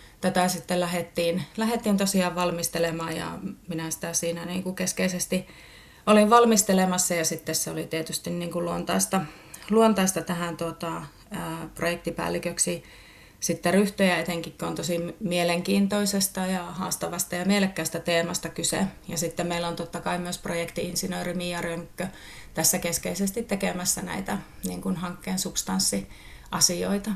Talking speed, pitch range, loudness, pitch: 130 wpm, 170-185 Hz, -26 LUFS, 175 Hz